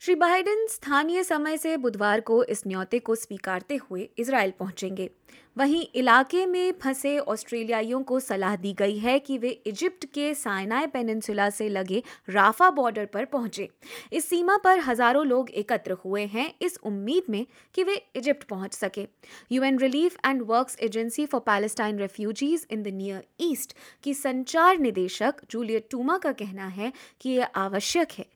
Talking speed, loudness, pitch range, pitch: 160 wpm, -26 LUFS, 210-290 Hz, 245 Hz